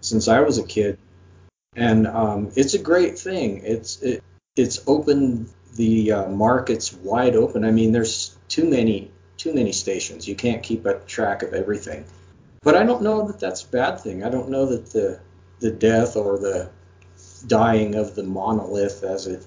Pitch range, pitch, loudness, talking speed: 95-120 Hz, 110 Hz, -21 LUFS, 180 wpm